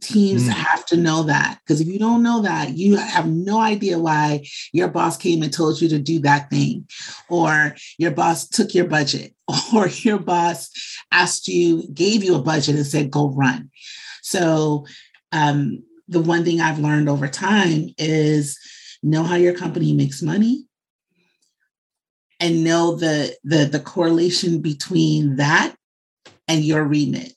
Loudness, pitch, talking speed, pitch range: -19 LUFS, 165 Hz, 160 wpm, 150-180 Hz